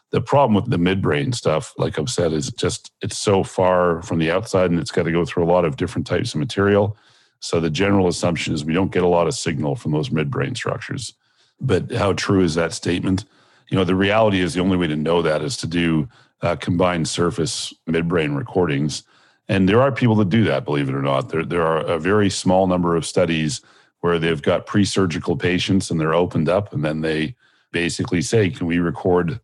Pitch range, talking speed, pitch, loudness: 85-95 Hz, 220 wpm, 90 Hz, -20 LUFS